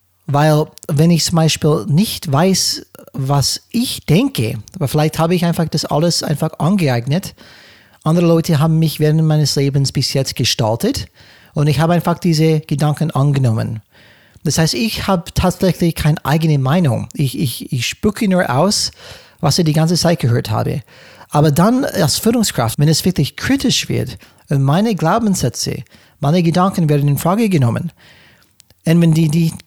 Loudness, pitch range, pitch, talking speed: -15 LUFS, 140-170 Hz, 155 Hz, 160 wpm